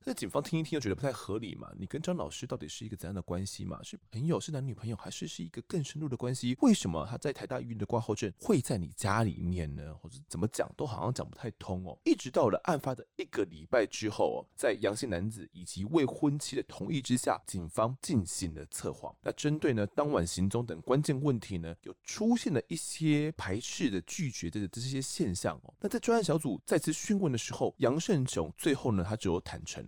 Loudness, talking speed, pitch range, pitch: -33 LUFS, 345 characters per minute, 95-150 Hz, 115 Hz